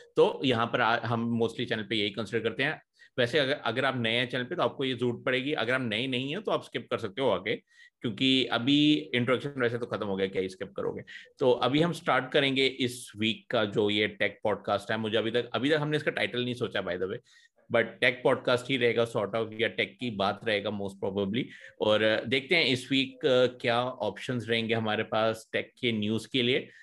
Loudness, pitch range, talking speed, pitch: -28 LUFS, 110-135 Hz, 235 wpm, 120 Hz